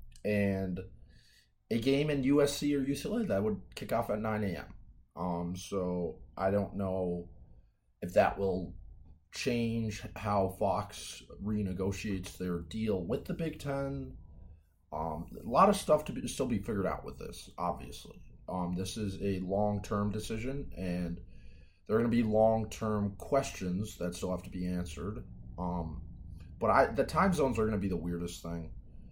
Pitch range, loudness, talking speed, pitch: 85-110 Hz, -33 LUFS, 165 wpm, 95 Hz